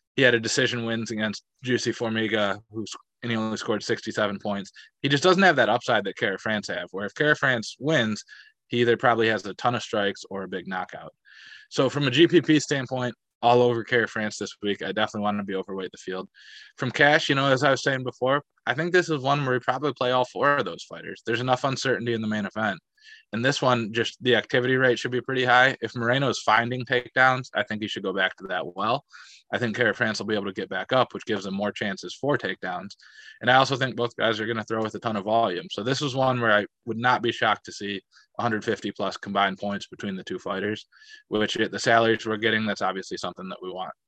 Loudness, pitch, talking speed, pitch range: -24 LUFS, 120 Hz, 245 wpm, 110-130 Hz